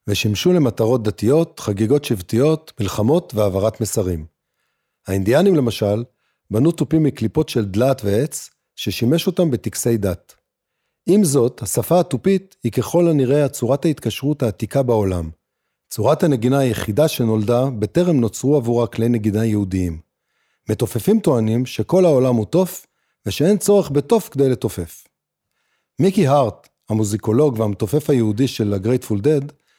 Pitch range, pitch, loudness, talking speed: 110-150 Hz, 120 Hz, -18 LUFS, 120 wpm